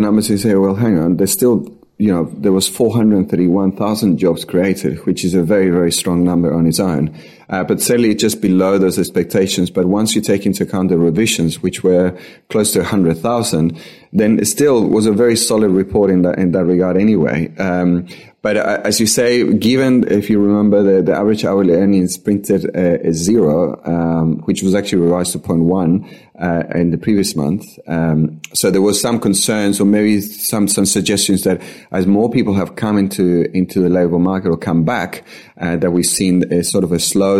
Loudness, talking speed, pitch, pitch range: -14 LUFS, 205 wpm, 95 Hz, 90-105 Hz